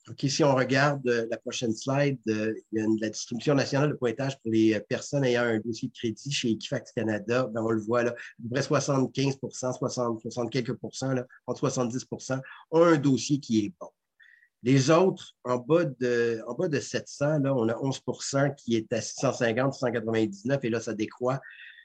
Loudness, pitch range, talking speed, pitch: -28 LUFS, 115-140 Hz, 200 wpm, 125 Hz